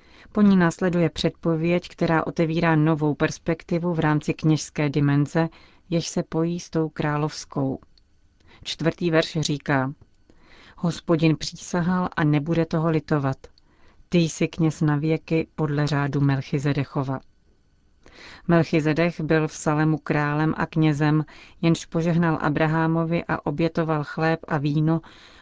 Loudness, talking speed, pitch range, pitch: -23 LUFS, 120 wpm, 150-165 Hz, 160 Hz